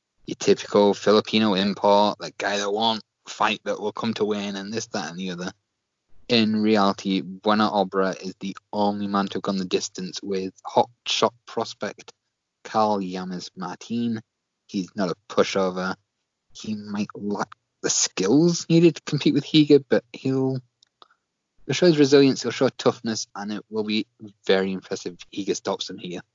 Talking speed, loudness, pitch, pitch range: 170 wpm, -23 LUFS, 105 Hz, 95-115 Hz